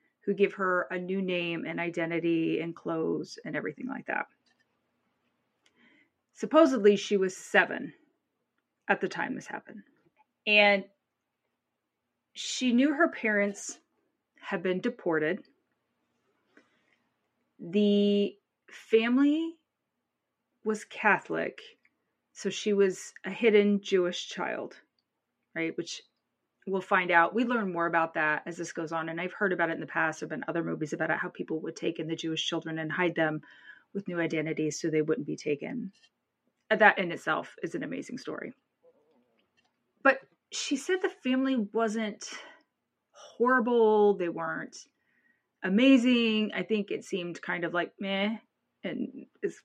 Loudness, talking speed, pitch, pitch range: -29 LUFS, 140 wpm, 200 Hz, 170-235 Hz